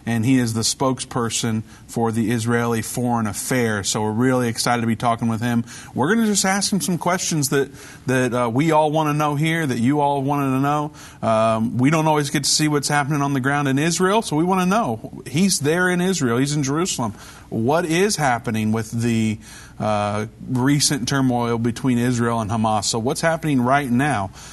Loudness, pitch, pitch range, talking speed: -20 LUFS, 130 Hz, 115-150 Hz, 210 wpm